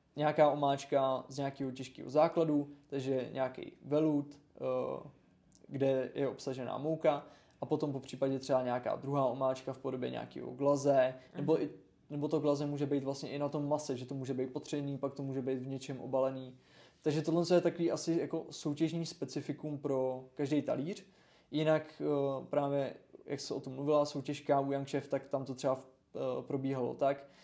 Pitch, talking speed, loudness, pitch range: 140 Hz, 165 wpm, -35 LUFS, 135-150 Hz